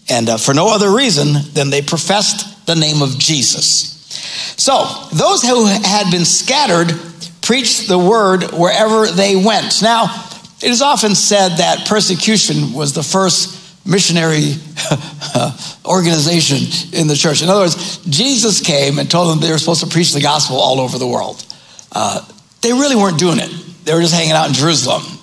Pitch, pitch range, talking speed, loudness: 170 Hz, 155-200 Hz, 170 wpm, -12 LUFS